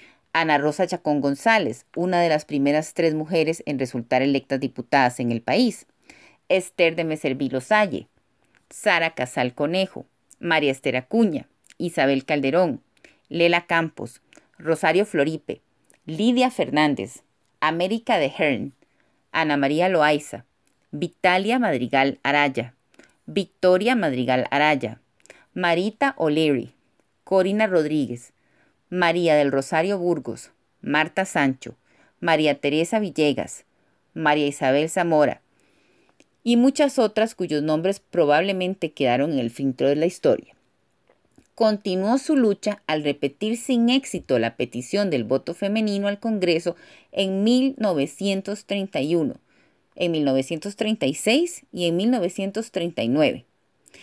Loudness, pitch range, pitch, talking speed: -22 LUFS, 145-200 Hz, 170 Hz, 105 wpm